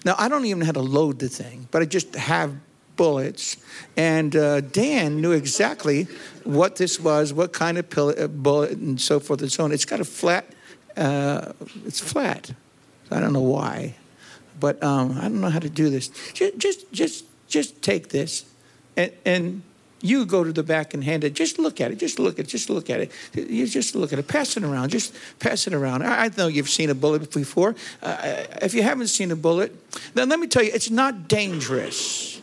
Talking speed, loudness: 215 wpm, -23 LUFS